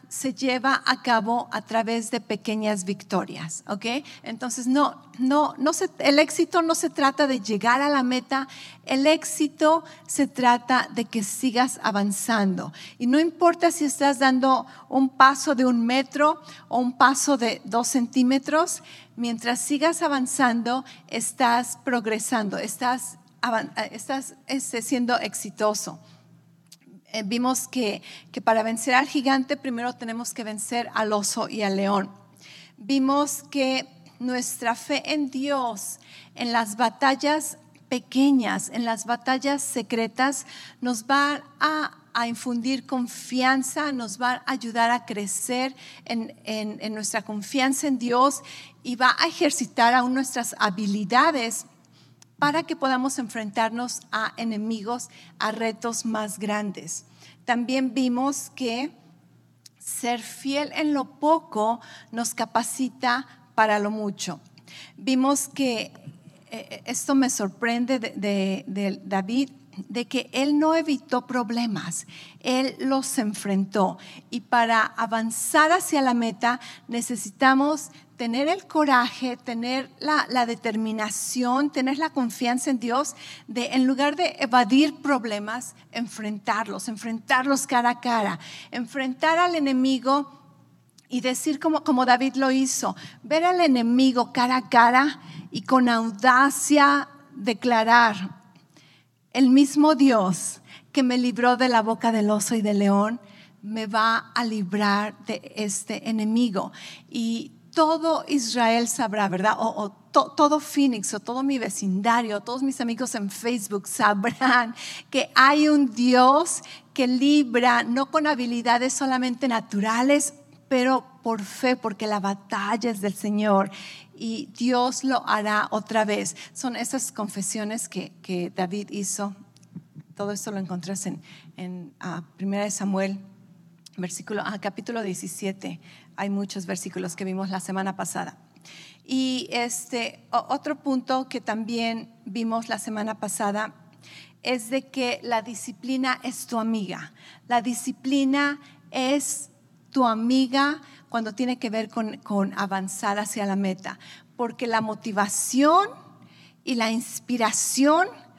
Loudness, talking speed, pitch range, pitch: -24 LUFS, 130 wpm, 215-265 Hz, 240 Hz